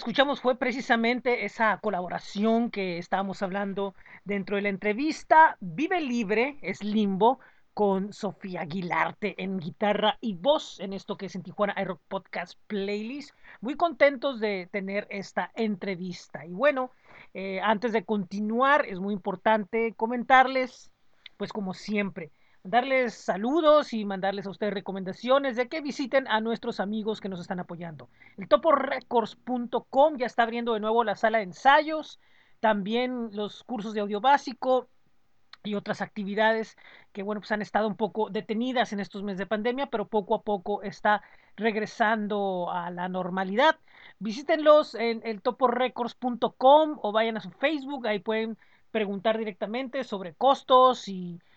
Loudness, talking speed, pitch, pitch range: -27 LUFS, 150 wpm, 220 Hz, 200-250 Hz